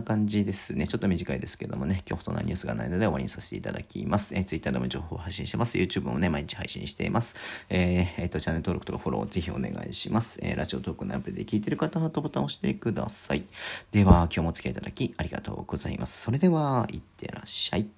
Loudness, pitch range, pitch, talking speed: -29 LUFS, 85-115 Hz, 100 Hz, 580 characters per minute